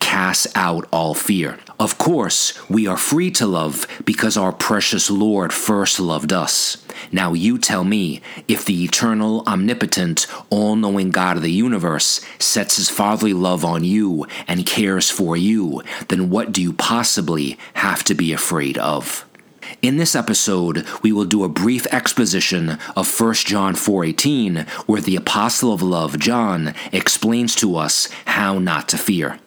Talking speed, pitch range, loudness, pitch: 155 wpm, 90-110 Hz, -17 LUFS, 95 Hz